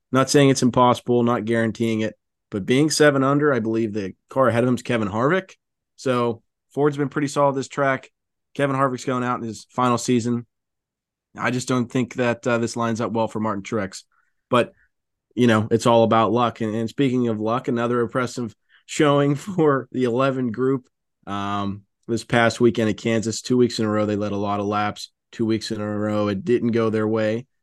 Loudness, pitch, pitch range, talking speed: -21 LUFS, 120 Hz, 110-130 Hz, 205 wpm